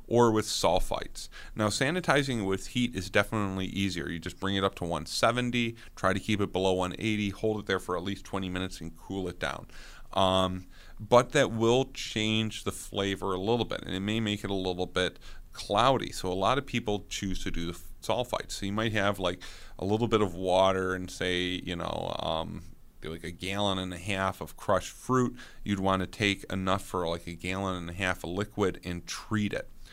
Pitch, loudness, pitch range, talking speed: 95 Hz, -30 LUFS, 90-110 Hz, 215 wpm